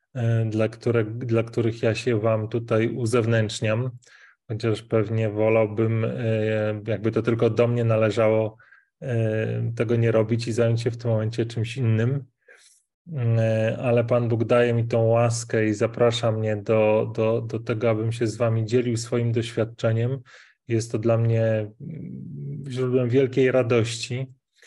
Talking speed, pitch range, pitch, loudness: 140 wpm, 110-120 Hz, 115 Hz, -23 LUFS